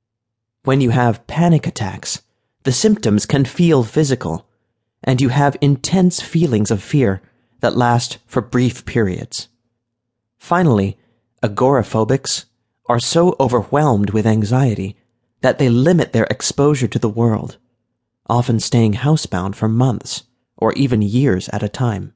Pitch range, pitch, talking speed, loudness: 115-135 Hz, 120 Hz, 130 wpm, -17 LUFS